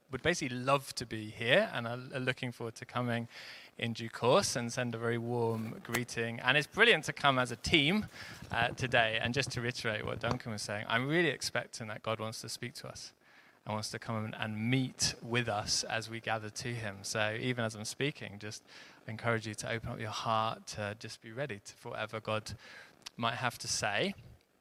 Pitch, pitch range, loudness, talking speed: 115 Hz, 110-125 Hz, -34 LUFS, 215 wpm